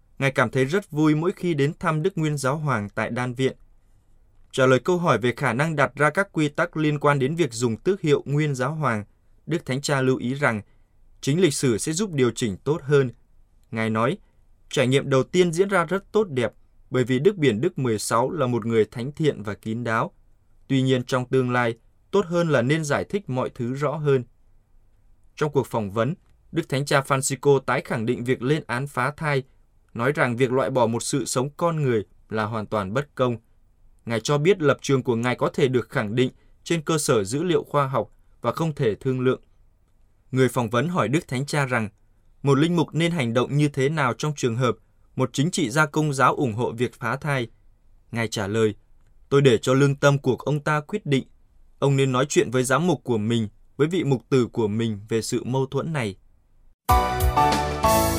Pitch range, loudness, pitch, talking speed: 110-145 Hz, -23 LUFS, 130 Hz, 220 wpm